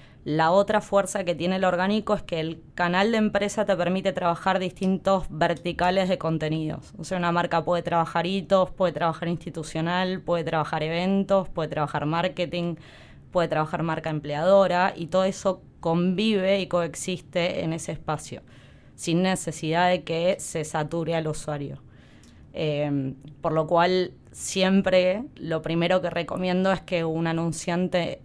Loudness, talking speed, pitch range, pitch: -25 LUFS, 150 wpm, 160-185 Hz, 175 Hz